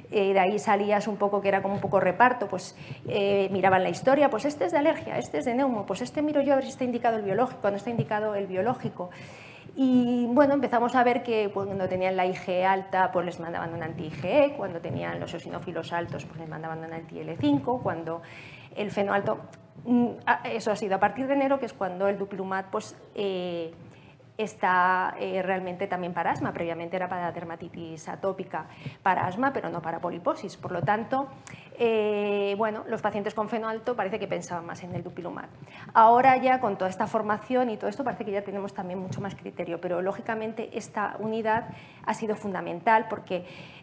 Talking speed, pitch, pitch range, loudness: 200 wpm, 200 Hz, 175-225 Hz, -27 LUFS